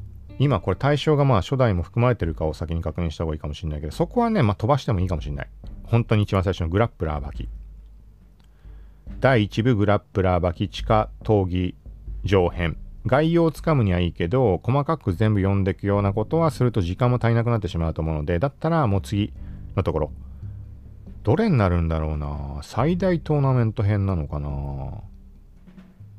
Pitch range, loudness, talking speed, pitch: 85-120 Hz, -23 LUFS, 390 characters per minute, 100 Hz